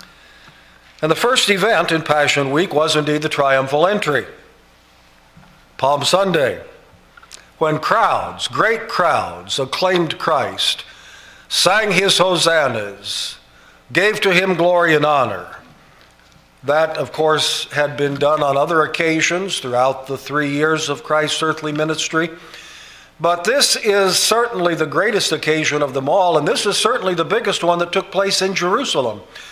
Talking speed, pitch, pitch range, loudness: 140 wpm, 160 Hz, 145-185 Hz, -16 LUFS